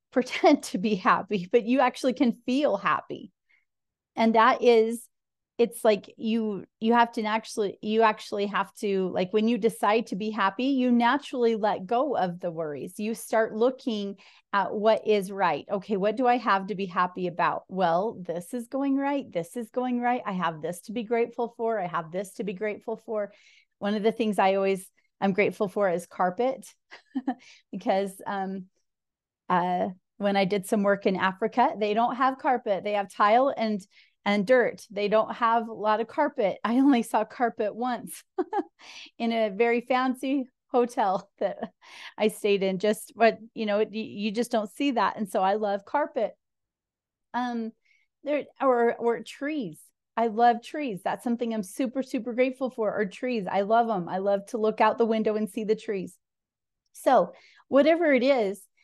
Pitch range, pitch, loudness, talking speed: 205-245 Hz, 225 Hz, -26 LUFS, 180 wpm